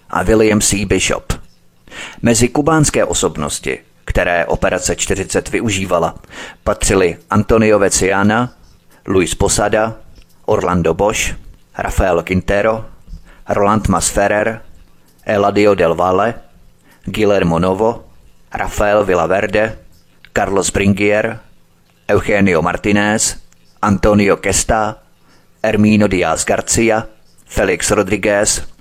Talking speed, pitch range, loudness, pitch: 85 wpm, 90-110 Hz, -14 LUFS, 100 Hz